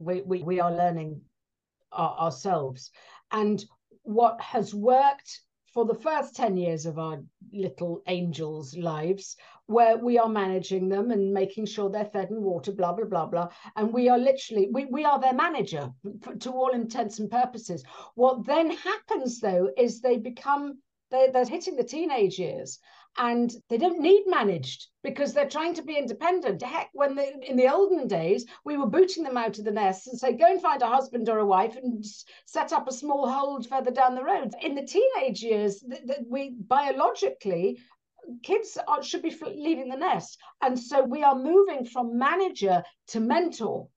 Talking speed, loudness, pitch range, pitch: 185 wpm, -26 LUFS, 200-280 Hz, 245 Hz